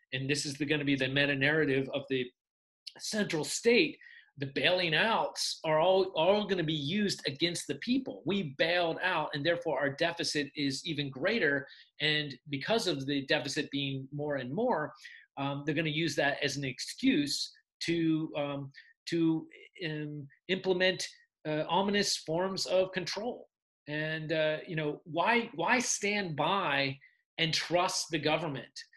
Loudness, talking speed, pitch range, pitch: -31 LUFS, 155 wpm, 145-185 Hz, 160 Hz